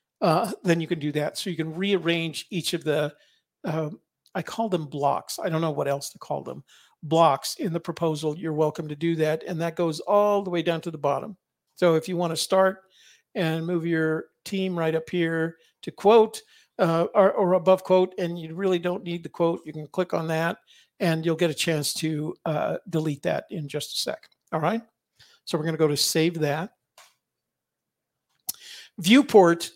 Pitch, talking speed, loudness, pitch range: 170 Hz, 205 wpm, -25 LUFS, 160-185 Hz